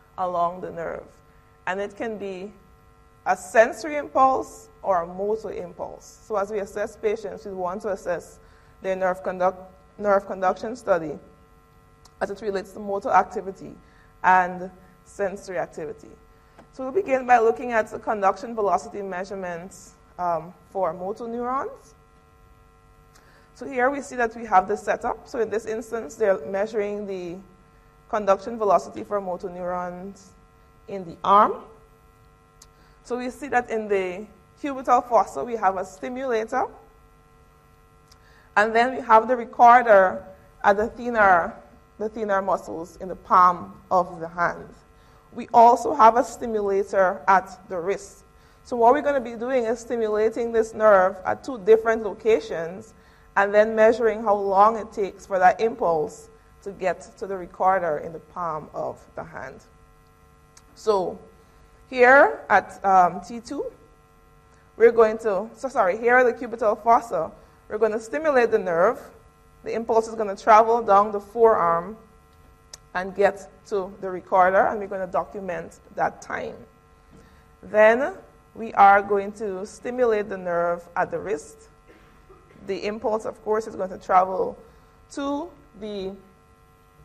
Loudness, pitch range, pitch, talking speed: -22 LUFS, 185-230 Hz, 205 Hz, 145 wpm